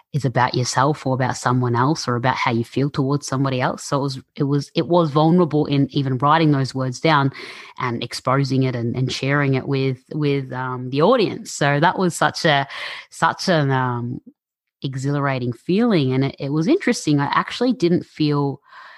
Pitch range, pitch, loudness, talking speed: 130-155 Hz, 140 Hz, -20 LUFS, 190 wpm